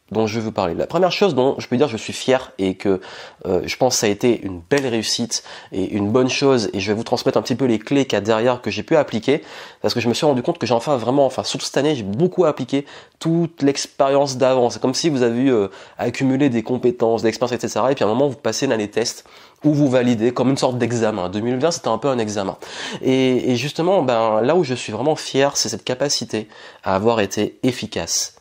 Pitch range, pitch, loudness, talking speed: 110-140 Hz, 125 Hz, -19 LUFS, 260 wpm